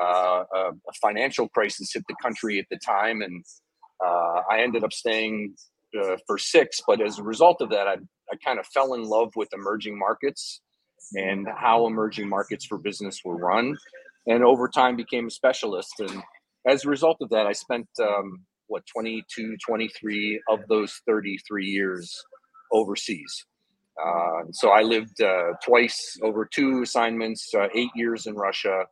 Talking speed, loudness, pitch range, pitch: 165 wpm, -24 LUFS, 100-125 Hz, 110 Hz